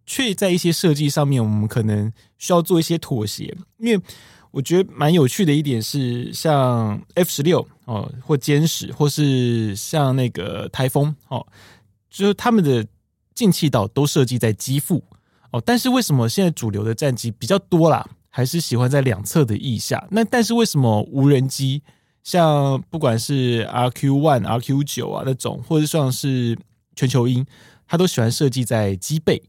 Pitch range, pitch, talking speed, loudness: 115-160 Hz, 135 Hz, 260 characters per minute, -19 LUFS